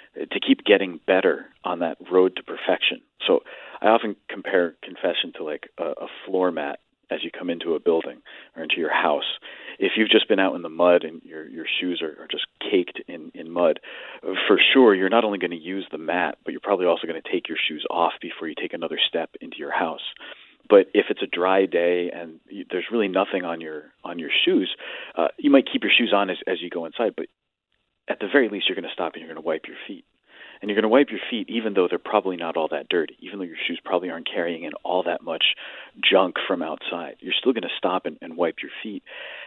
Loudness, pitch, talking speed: -23 LUFS, 95 Hz, 245 wpm